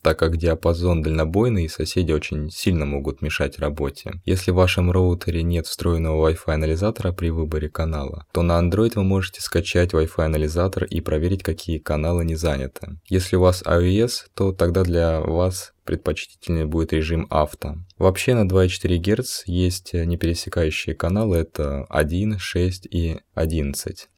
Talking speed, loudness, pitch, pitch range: 150 wpm, -22 LUFS, 85 Hz, 80-95 Hz